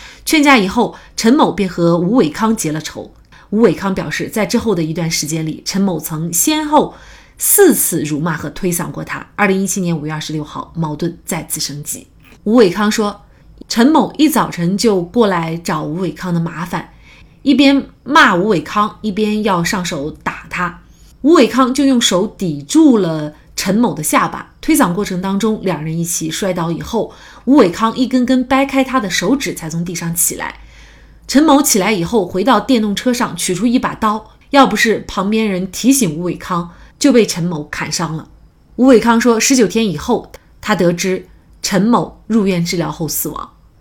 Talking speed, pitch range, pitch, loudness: 265 characters per minute, 170-235 Hz, 195 Hz, -14 LUFS